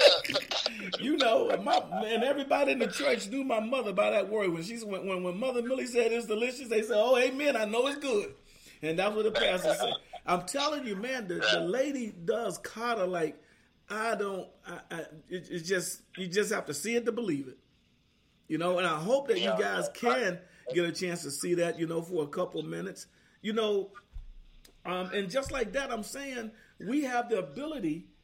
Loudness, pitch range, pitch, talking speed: -31 LUFS, 180-255 Hz, 215 Hz, 205 wpm